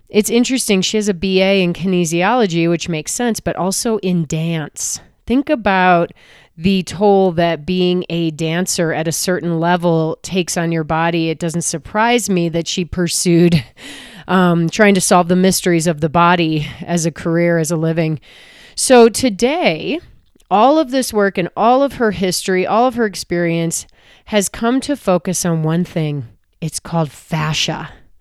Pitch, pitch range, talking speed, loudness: 175 Hz, 165-200 Hz, 165 wpm, -16 LUFS